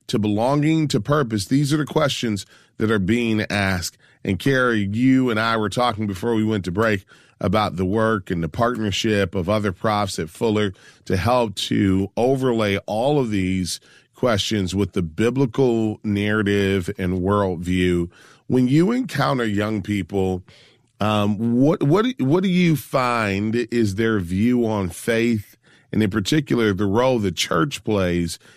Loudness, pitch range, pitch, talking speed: -21 LUFS, 100-125 Hz, 110 Hz, 155 wpm